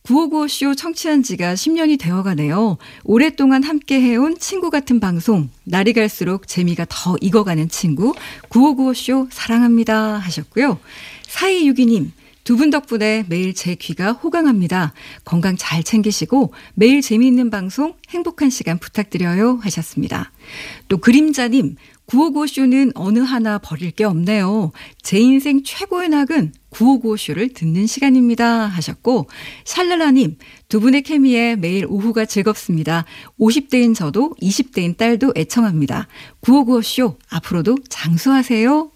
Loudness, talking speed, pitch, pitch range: -16 LUFS, 280 characters per minute, 230 Hz, 185-270 Hz